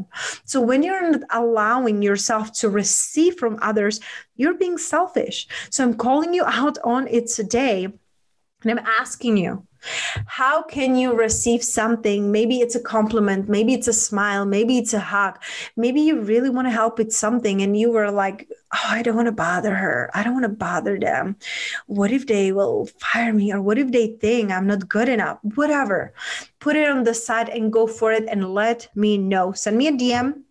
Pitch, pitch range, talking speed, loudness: 230 Hz, 210-255 Hz, 195 wpm, -20 LUFS